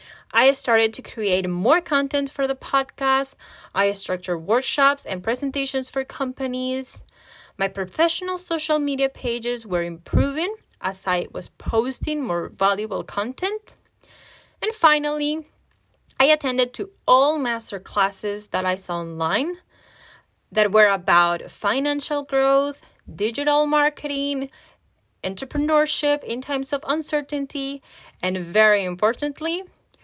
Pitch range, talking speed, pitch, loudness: 205-290 Hz, 115 wpm, 265 Hz, -22 LUFS